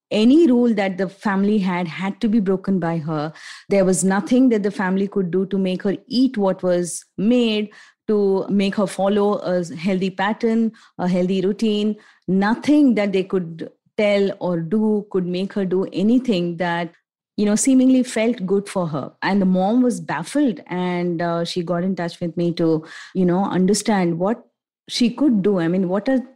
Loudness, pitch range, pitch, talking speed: -20 LUFS, 180-215 Hz, 195 Hz, 185 wpm